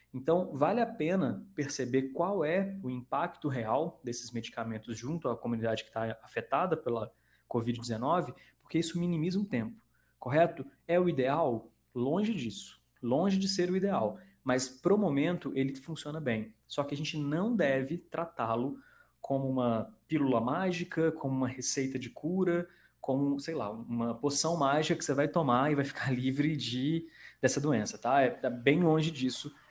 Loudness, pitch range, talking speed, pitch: -32 LUFS, 125-165 Hz, 165 wpm, 140 Hz